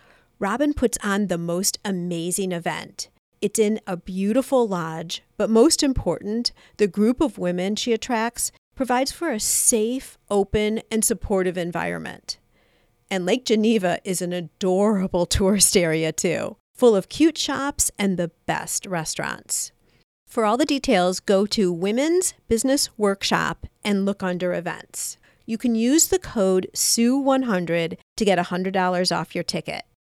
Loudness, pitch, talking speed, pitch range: -22 LUFS, 205 Hz, 140 wpm, 180-235 Hz